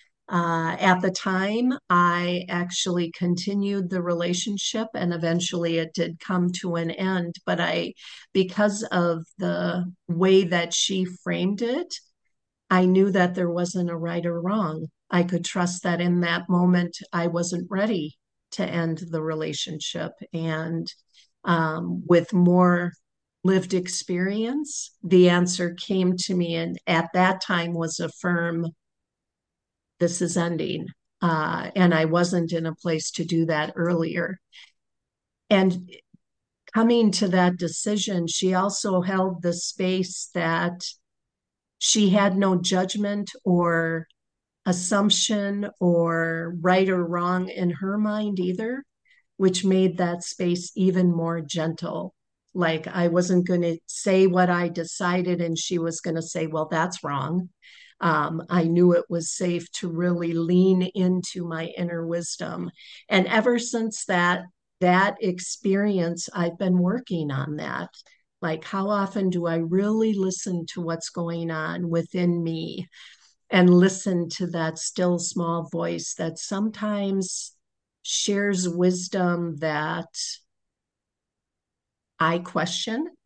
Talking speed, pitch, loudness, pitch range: 130 wpm, 175 Hz, -24 LUFS, 170-190 Hz